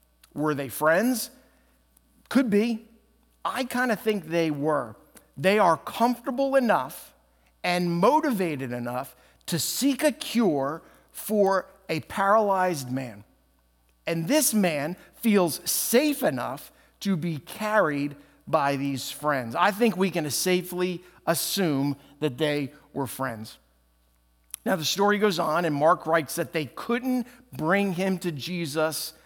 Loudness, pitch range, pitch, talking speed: -26 LUFS, 140-210 Hz, 170 Hz, 130 wpm